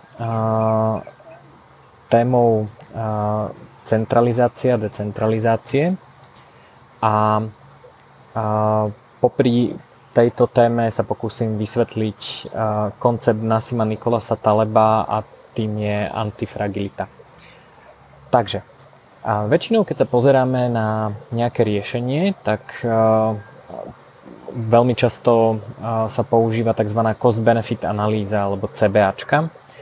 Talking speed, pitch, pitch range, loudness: 70 wpm, 115 Hz, 110-120 Hz, -19 LUFS